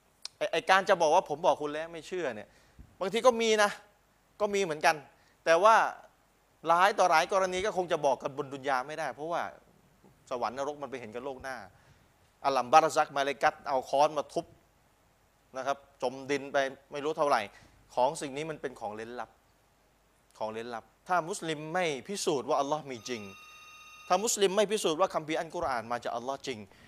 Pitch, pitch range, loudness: 155 Hz, 135-185 Hz, -30 LUFS